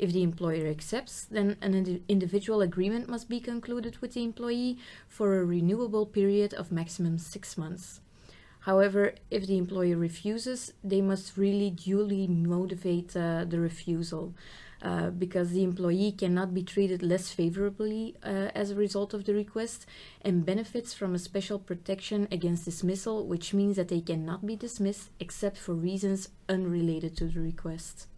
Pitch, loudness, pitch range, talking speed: 190 Hz, -31 LUFS, 175-205 Hz, 160 wpm